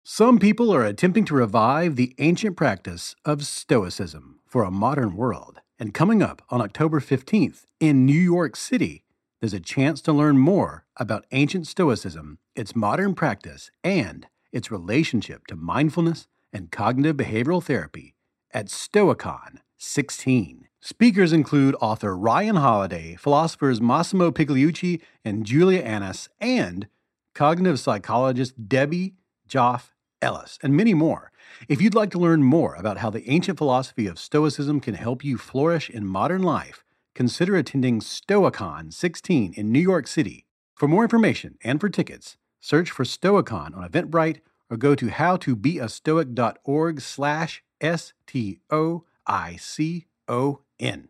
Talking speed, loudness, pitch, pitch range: 135 wpm, -22 LUFS, 140 Hz, 115-165 Hz